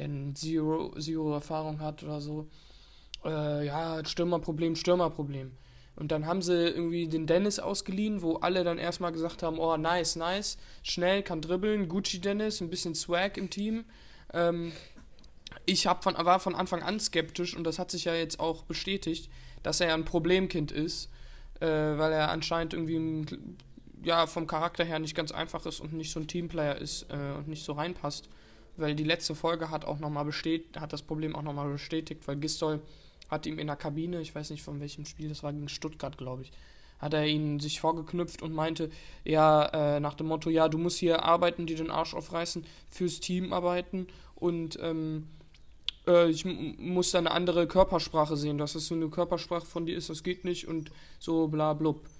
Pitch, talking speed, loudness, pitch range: 160 Hz, 190 wpm, -31 LUFS, 155-175 Hz